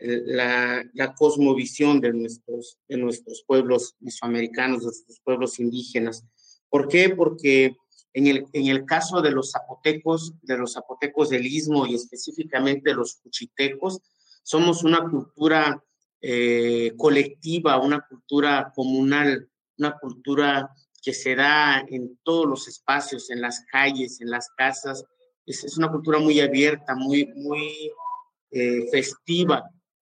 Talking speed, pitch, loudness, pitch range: 130 wpm, 135 Hz, -23 LUFS, 125-150 Hz